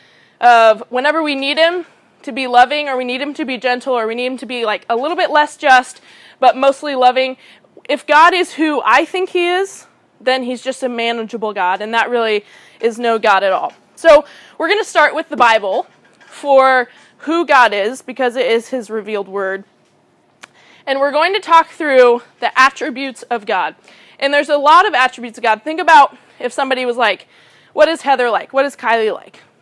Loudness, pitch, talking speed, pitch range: -14 LUFS, 260 Hz, 205 wpm, 235-300 Hz